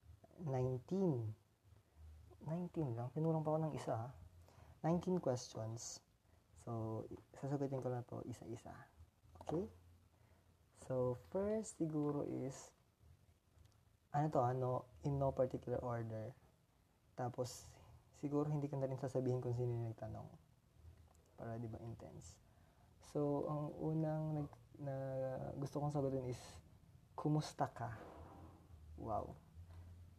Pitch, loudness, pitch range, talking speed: 120 Hz, -43 LUFS, 95-140 Hz, 110 wpm